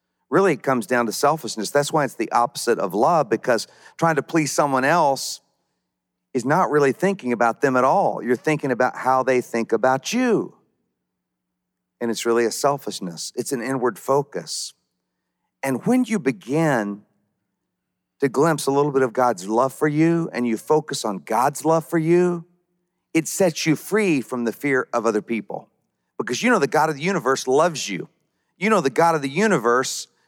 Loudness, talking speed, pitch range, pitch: -21 LUFS, 185 wpm, 120-160 Hz, 135 Hz